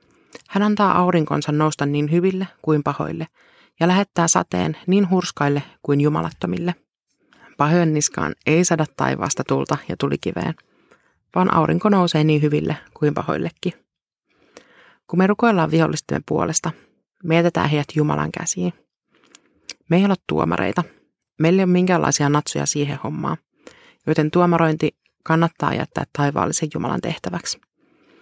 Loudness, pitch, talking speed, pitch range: -20 LUFS, 165 Hz, 120 wpm, 150-180 Hz